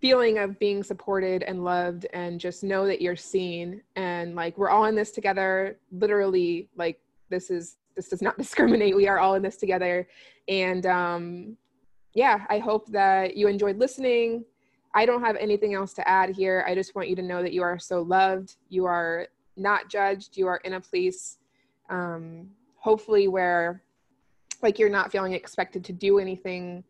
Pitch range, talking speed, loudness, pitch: 180-205 Hz, 180 wpm, -25 LUFS, 190 Hz